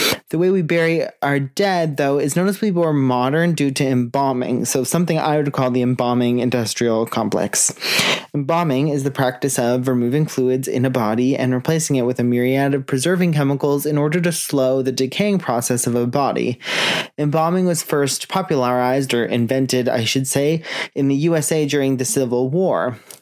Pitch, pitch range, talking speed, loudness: 140 Hz, 125-155 Hz, 180 wpm, -18 LUFS